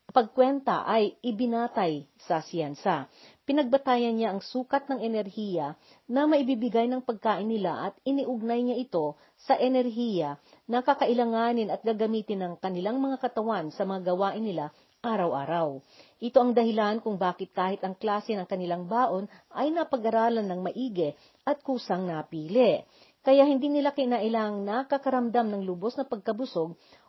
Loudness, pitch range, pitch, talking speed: -28 LUFS, 190-255 Hz, 225 Hz, 135 wpm